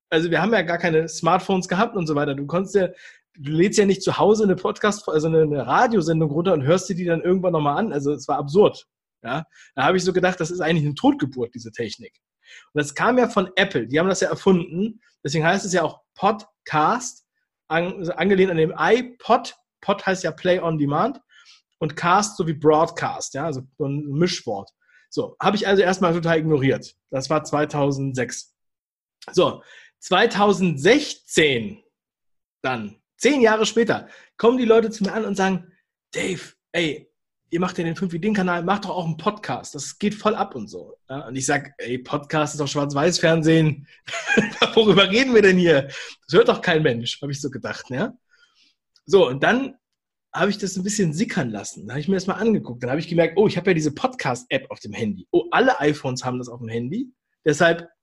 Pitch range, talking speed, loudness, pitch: 150-205 Hz, 200 wpm, -21 LUFS, 175 Hz